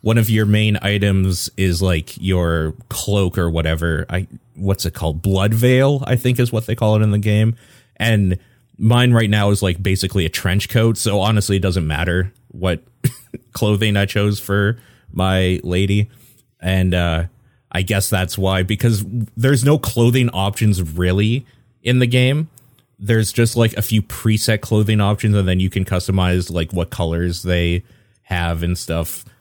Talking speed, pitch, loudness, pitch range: 170 wpm, 100 Hz, -18 LUFS, 90-115 Hz